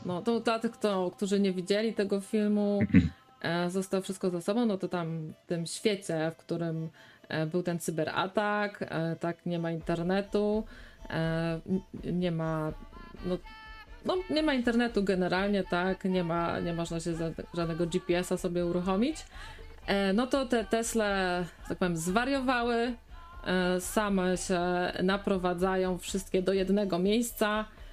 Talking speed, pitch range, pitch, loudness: 145 wpm, 170-210 Hz, 185 Hz, -31 LUFS